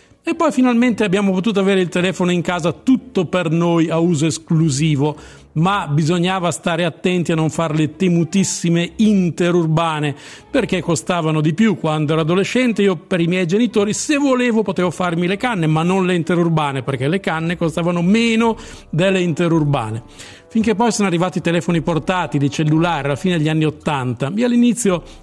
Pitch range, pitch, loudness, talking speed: 160-195 Hz, 175 Hz, -17 LUFS, 170 wpm